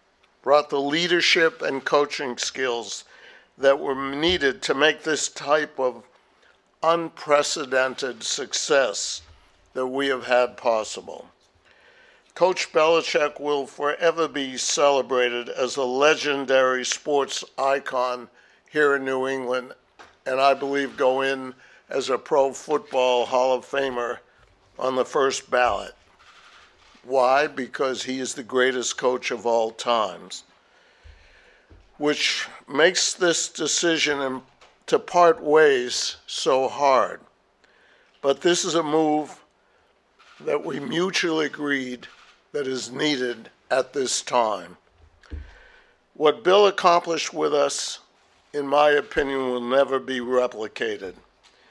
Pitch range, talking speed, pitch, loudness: 125-150 Hz, 115 wpm, 135 Hz, -23 LUFS